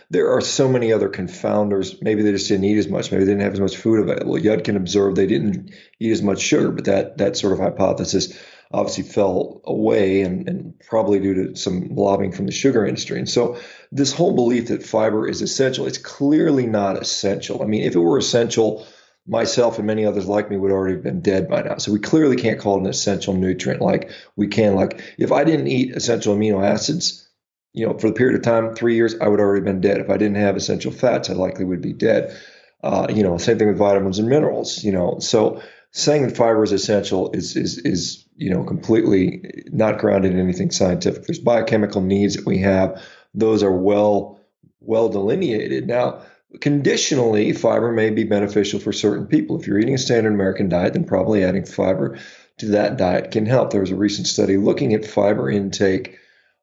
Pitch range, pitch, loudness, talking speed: 100-115 Hz, 105 Hz, -19 LUFS, 210 wpm